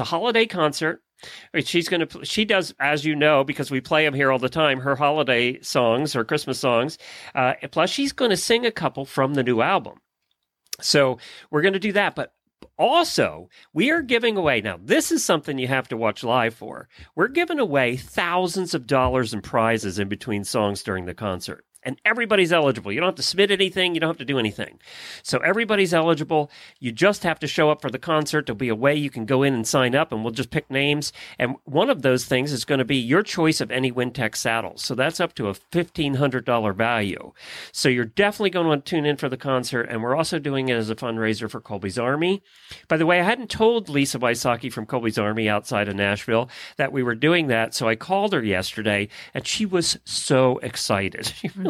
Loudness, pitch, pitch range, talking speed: -22 LUFS, 135 Hz, 120-170 Hz, 225 wpm